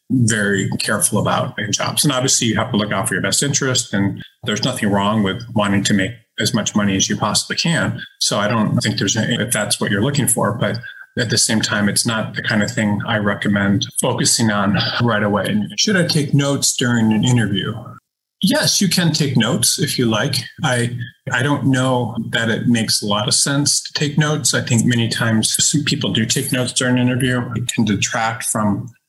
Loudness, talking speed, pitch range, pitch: -17 LUFS, 215 wpm, 105-135 Hz, 120 Hz